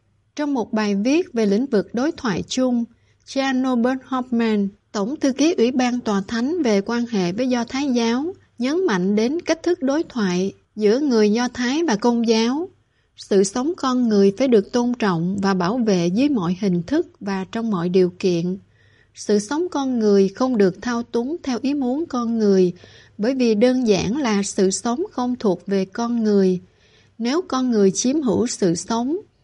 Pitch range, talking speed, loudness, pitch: 200-260 Hz, 190 wpm, -20 LUFS, 235 Hz